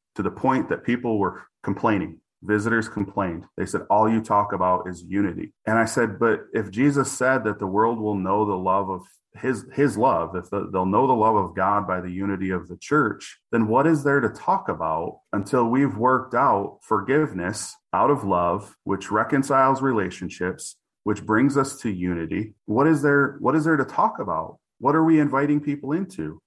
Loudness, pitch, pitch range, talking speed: -23 LUFS, 110 Hz, 100-135 Hz, 195 wpm